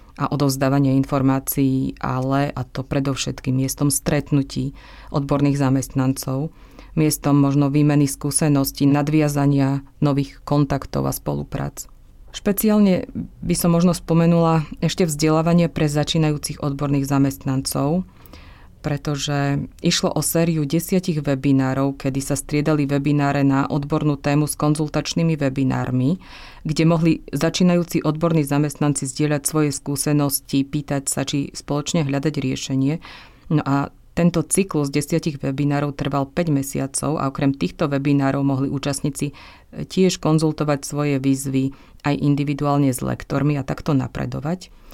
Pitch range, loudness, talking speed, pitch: 135-155 Hz, -20 LUFS, 120 wpm, 145 Hz